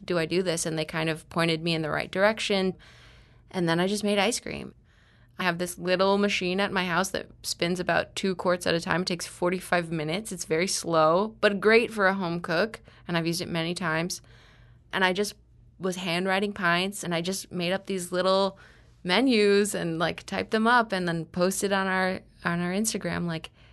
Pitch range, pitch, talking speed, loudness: 165-195 Hz, 180 Hz, 210 wpm, -26 LUFS